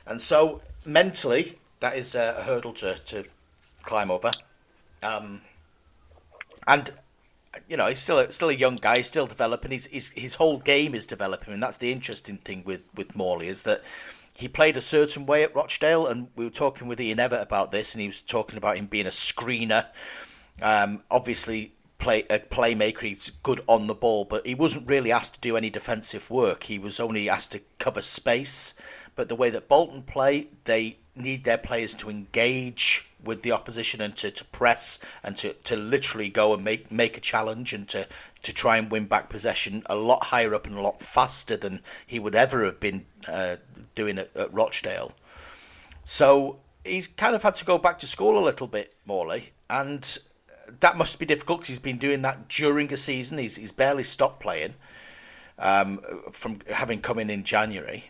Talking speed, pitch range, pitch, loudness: 195 wpm, 105-135 Hz, 115 Hz, -25 LUFS